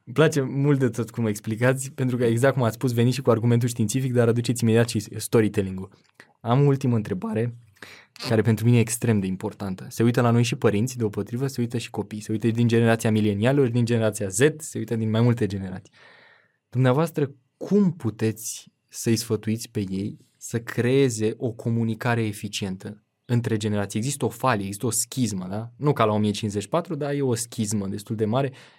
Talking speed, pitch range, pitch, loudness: 190 wpm, 110-125 Hz, 115 Hz, -24 LUFS